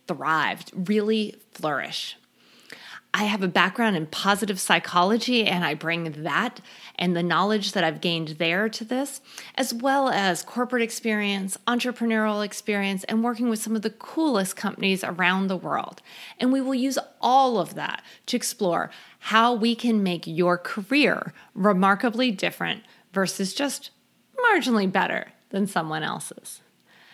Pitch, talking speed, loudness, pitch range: 210 Hz, 145 wpm, -24 LUFS, 185-240 Hz